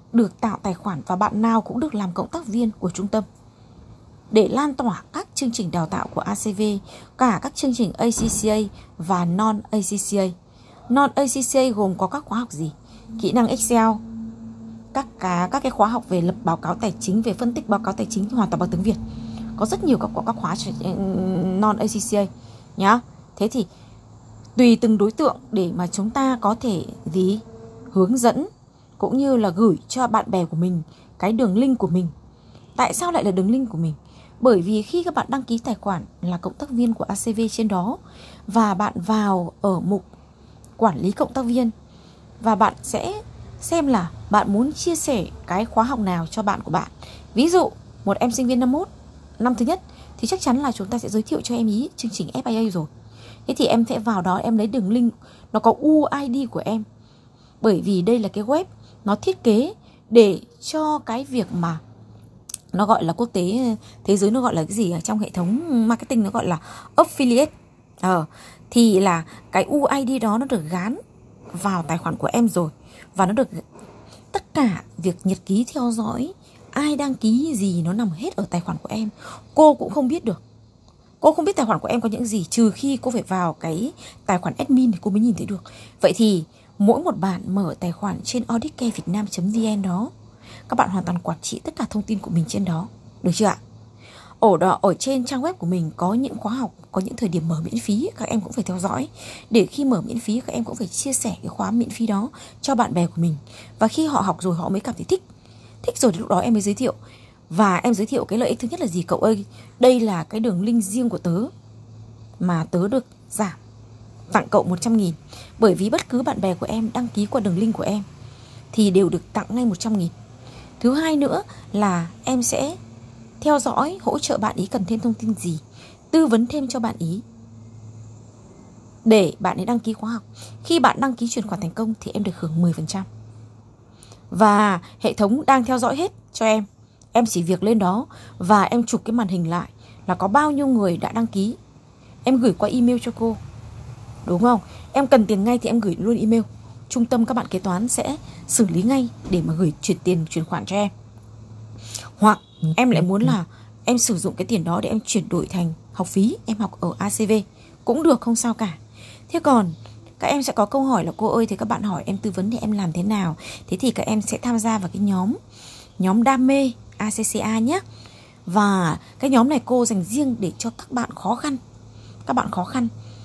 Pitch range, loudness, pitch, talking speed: 175-235 Hz, -21 LUFS, 210 Hz, 220 wpm